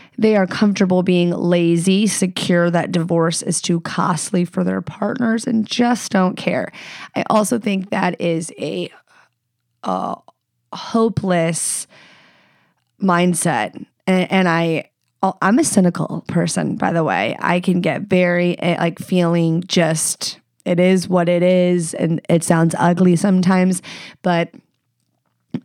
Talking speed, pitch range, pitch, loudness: 130 wpm, 170-190 Hz, 180 Hz, -18 LUFS